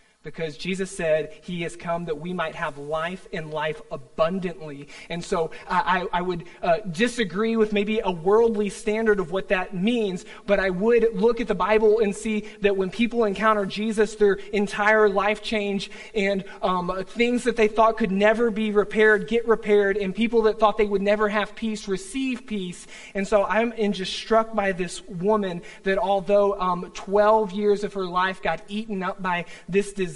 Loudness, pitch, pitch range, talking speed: -23 LUFS, 205 Hz, 185-215 Hz, 185 wpm